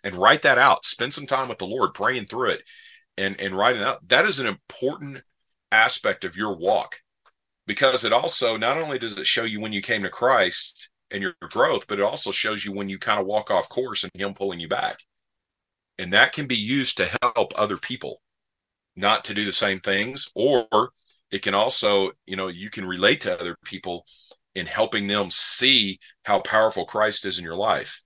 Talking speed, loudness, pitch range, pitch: 210 wpm, -22 LUFS, 95-110 Hz, 105 Hz